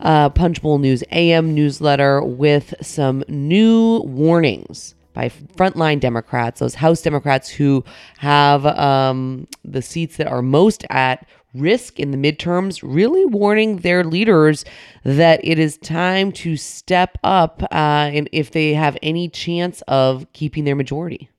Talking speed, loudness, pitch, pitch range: 145 wpm, -17 LUFS, 155 Hz, 140-170 Hz